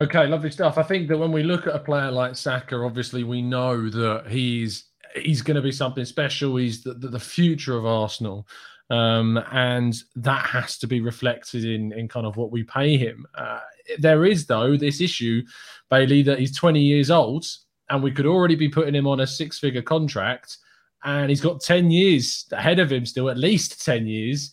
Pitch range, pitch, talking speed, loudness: 120-155 Hz, 135 Hz, 200 wpm, -22 LUFS